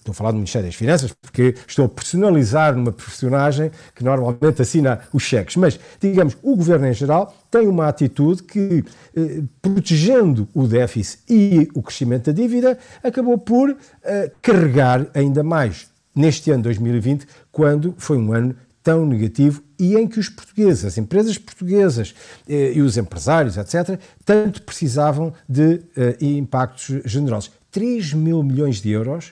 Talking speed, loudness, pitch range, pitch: 155 wpm, -18 LUFS, 125-175 Hz, 150 Hz